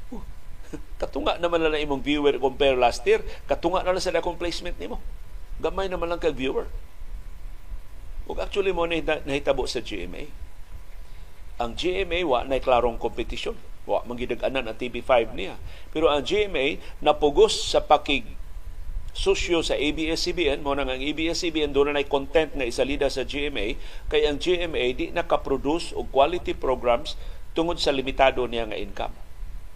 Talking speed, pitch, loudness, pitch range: 145 wpm, 145 Hz, -25 LUFS, 120-170 Hz